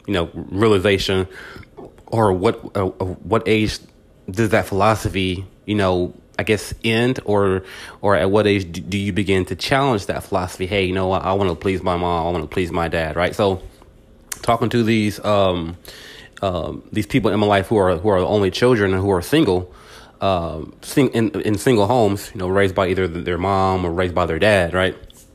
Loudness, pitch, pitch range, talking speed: -19 LUFS, 95 Hz, 90-105 Hz, 205 wpm